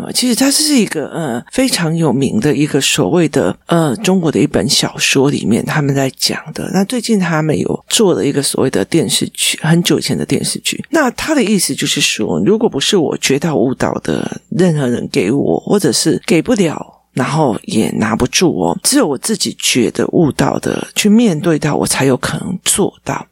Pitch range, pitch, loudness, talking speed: 150-225 Hz, 175 Hz, -13 LUFS, 290 characters per minute